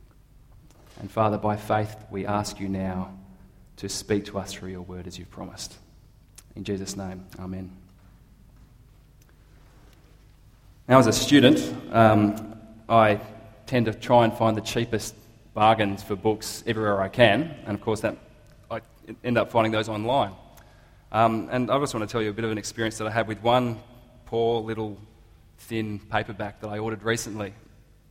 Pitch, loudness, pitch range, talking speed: 110 Hz, -24 LUFS, 100-115 Hz, 165 wpm